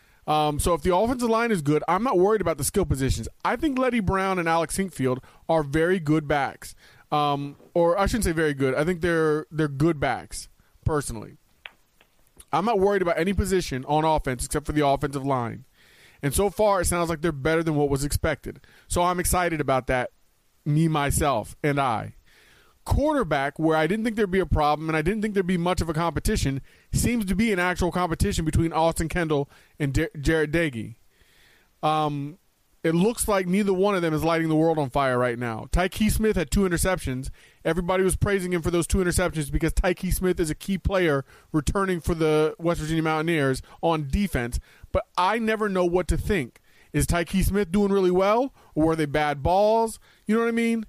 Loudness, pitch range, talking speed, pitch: -24 LUFS, 145-185 Hz, 205 wpm, 165 Hz